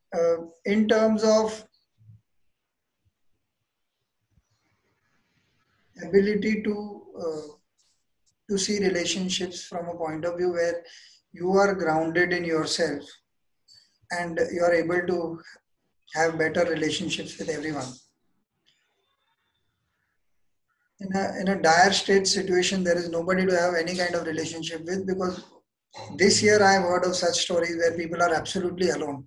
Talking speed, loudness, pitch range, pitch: 125 wpm, -24 LUFS, 160-190 Hz, 175 Hz